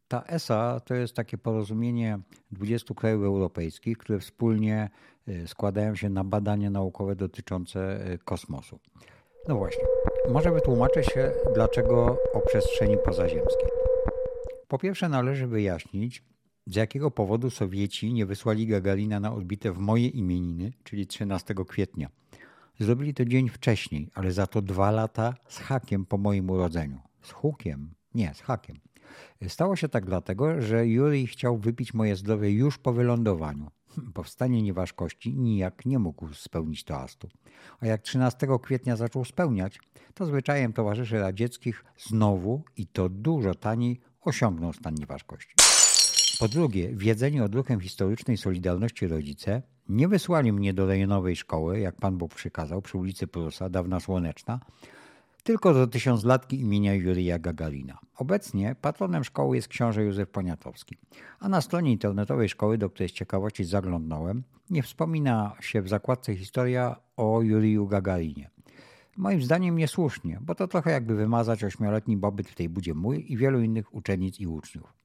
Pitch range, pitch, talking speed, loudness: 95-125 Hz, 110 Hz, 145 wpm, -27 LUFS